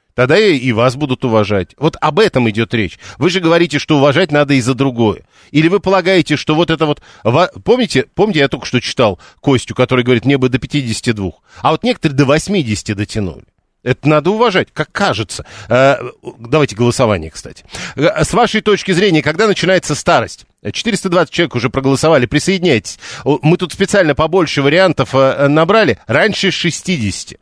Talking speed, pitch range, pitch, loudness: 160 wpm, 125-170 Hz, 145 Hz, -13 LUFS